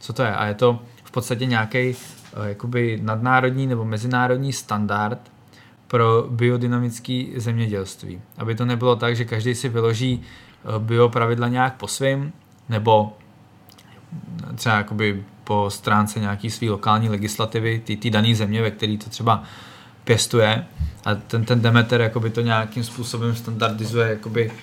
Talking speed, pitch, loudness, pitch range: 135 wpm, 115 Hz, -21 LUFS, 110-120 Hz